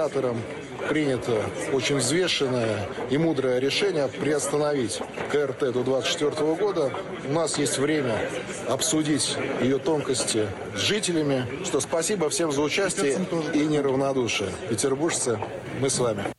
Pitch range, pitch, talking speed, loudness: 130-160 Hz, 140 Hz, 115 wpm, -25 LUFS